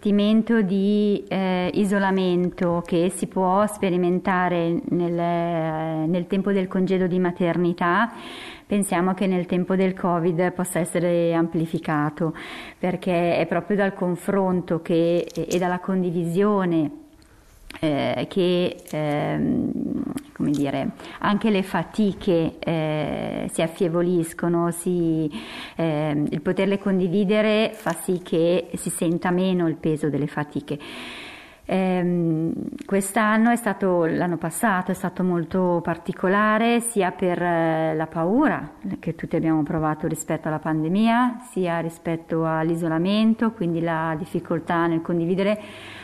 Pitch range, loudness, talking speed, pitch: 165-195 Hz, -23 LUFS, 115 wpm, 180 Hz